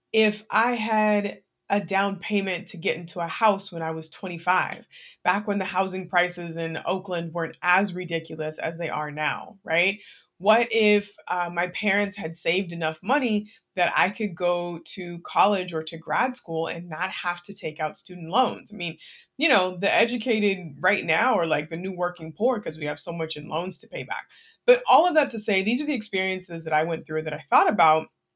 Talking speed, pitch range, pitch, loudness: 210 wpm, 165-205 Hz, 180 Hz, -25 LUFS